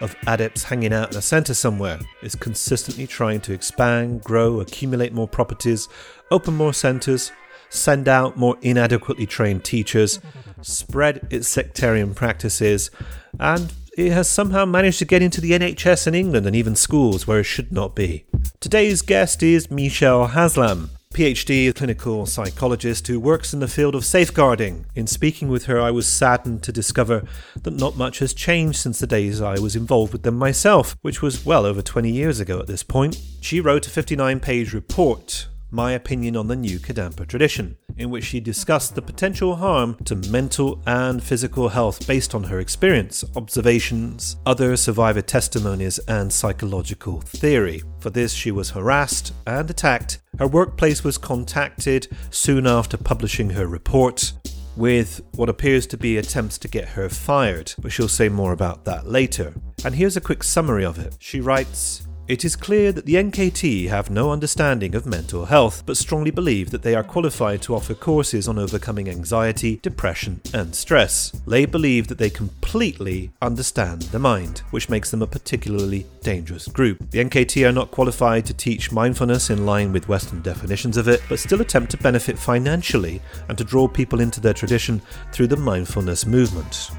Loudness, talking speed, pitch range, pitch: -20 LUFS, 175 wpm, 105-135 Hz, 120 Hz